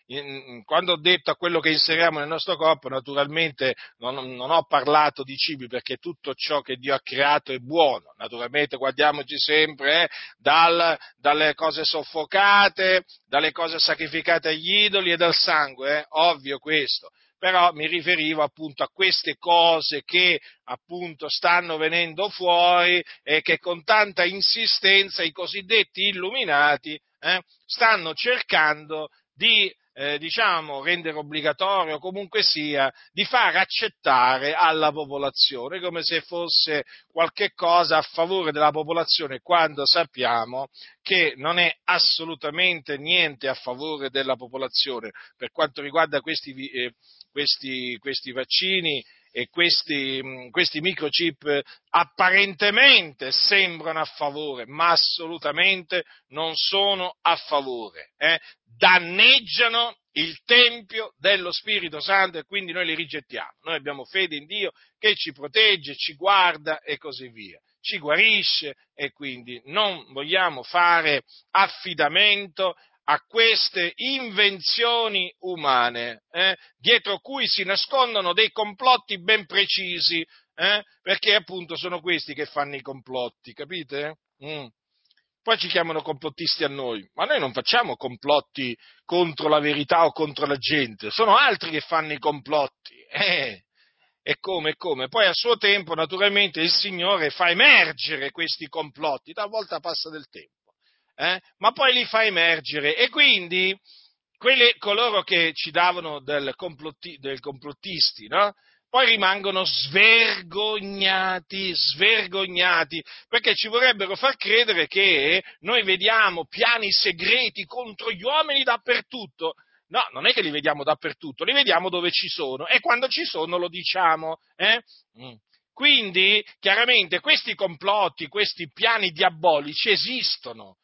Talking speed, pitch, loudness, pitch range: 130 wpm, 170 Hz, -21 LUFS, 150-195 Hz